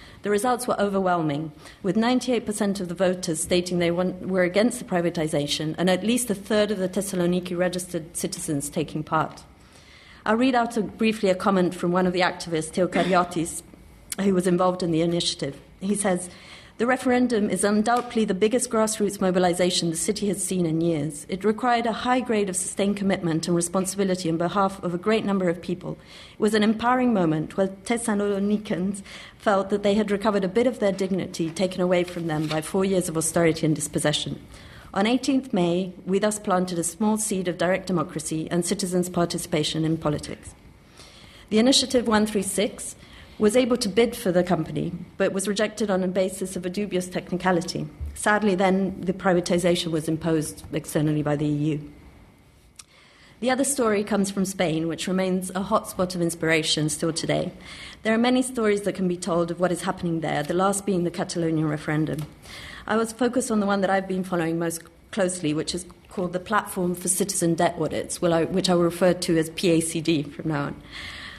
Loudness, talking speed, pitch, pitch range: -24 LUFS, 185 wpm, 185 Hz, 170-205 Hz